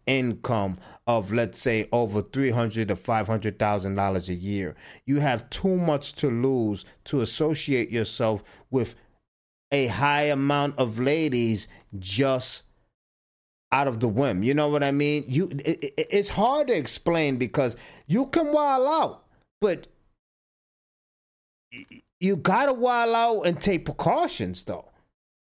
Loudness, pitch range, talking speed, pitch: -25 LUFS, 110-150 Hz, 135 wpm, 125 Hz